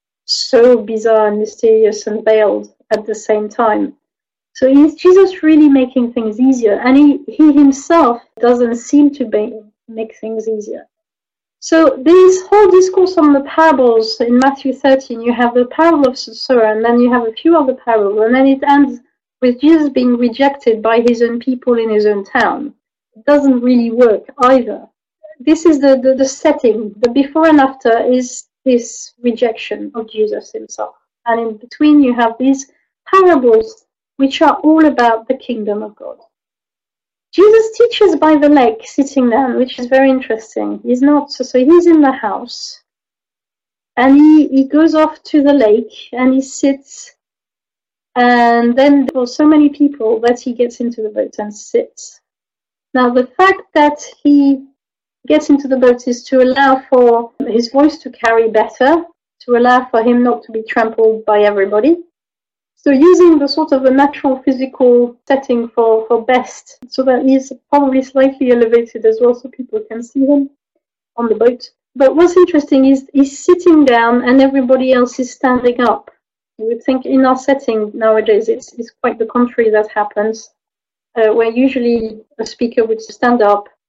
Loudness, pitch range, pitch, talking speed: -12 LUFS, 230-285 Hz, 255 Hz, 170 wpm